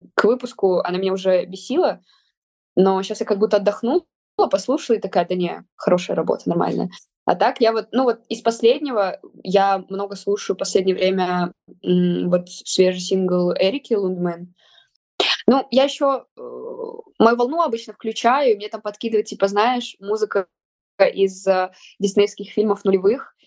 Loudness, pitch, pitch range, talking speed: -20 LUFS, 205 Hz, 190-235 Hz, 145 wpm